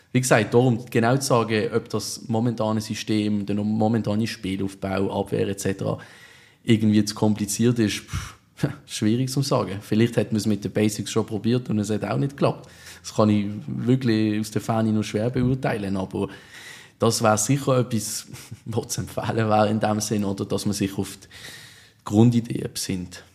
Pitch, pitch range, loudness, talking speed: 110 Hz, 105-115 Hz, -23 LUFS, 165 wpm